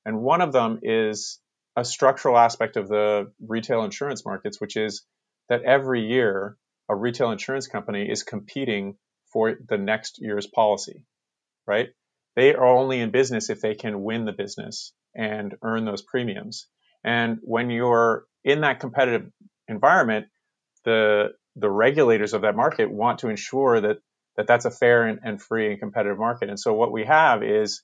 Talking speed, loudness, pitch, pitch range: 165 wpm, -23 LUFS, 115 Hz, 105-120 Hz